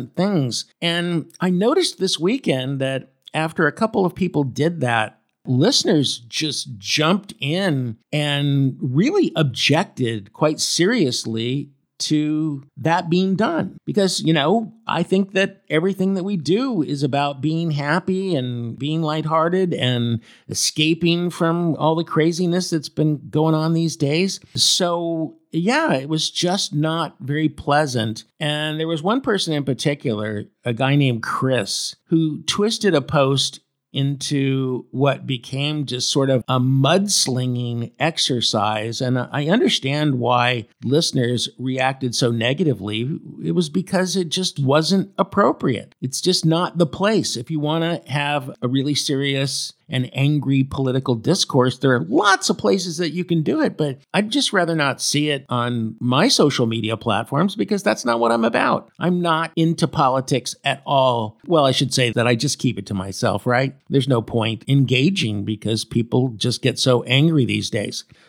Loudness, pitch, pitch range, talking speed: -20 LUFS, 145 Hz, 130-165 Hz, 155 wpm